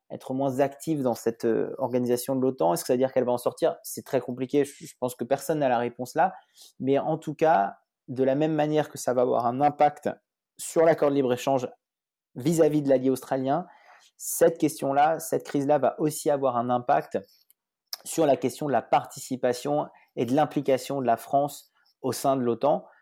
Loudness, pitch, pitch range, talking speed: -26 LUFS, 135 Hz, 130-150 Hz, 195 wpm